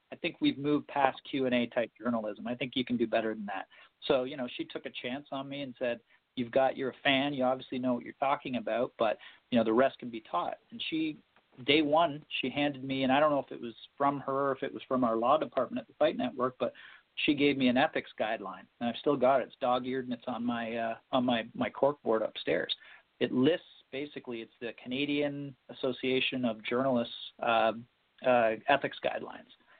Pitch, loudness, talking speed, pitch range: 130 Hz, -31 LUFS, 230 wpm, 120-140 Hz